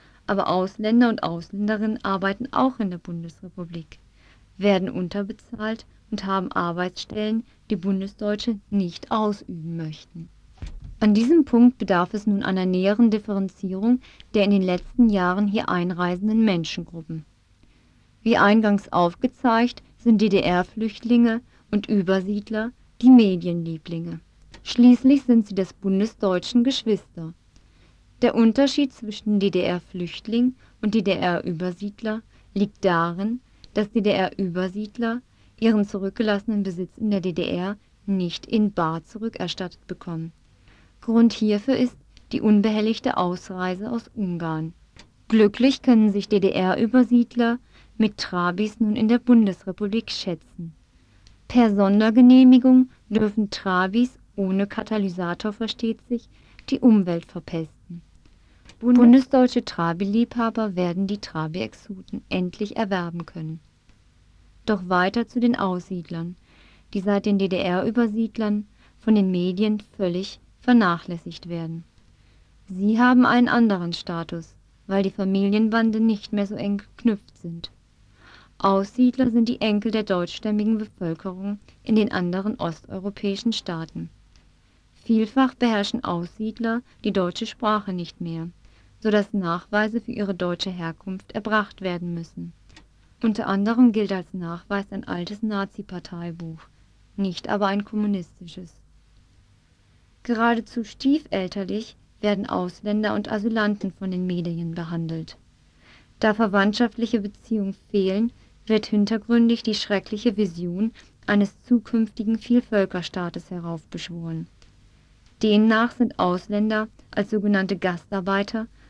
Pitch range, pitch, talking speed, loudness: 180-225 Hz, 200 Hz, 105 wpm, -22 LUFS